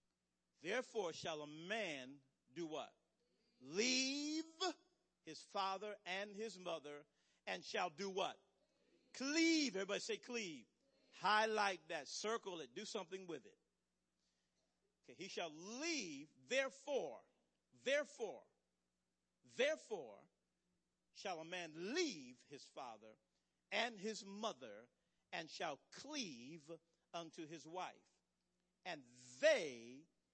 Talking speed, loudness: 105 wpm, -44 LUFS